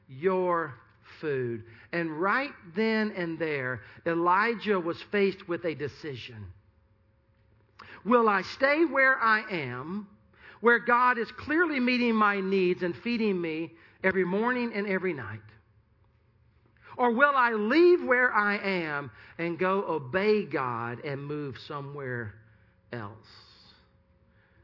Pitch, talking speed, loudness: 170 Hz, 120 wpm, -27 LUFS